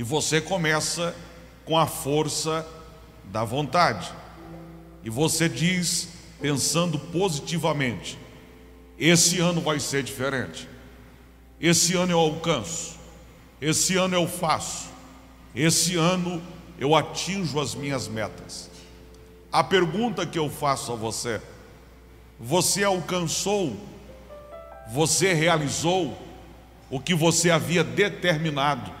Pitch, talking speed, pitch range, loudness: 155 Hz, 100 wpm, 120-170 Hz, -24 LUFS